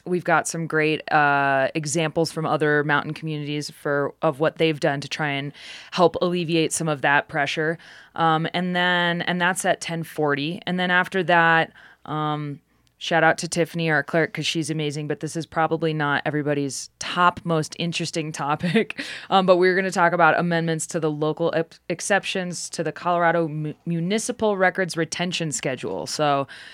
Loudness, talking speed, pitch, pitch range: -22 LUFS, 170 wpm, 160 Hz, 150-175 Hz